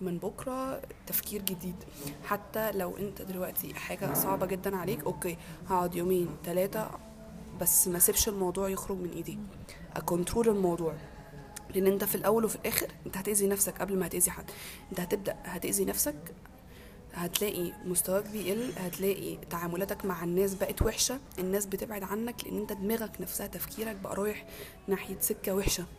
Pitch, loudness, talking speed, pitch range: 195 Hz, -31 LUFS, 150 wpm, 180-205 Hz